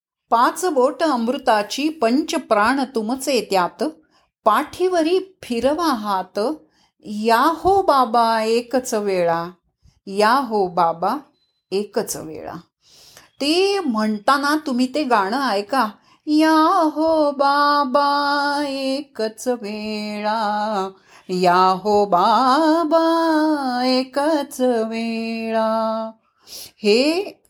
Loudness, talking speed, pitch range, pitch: -19 LUFS, 75 wpm, 215-300 Hz, 255 Hz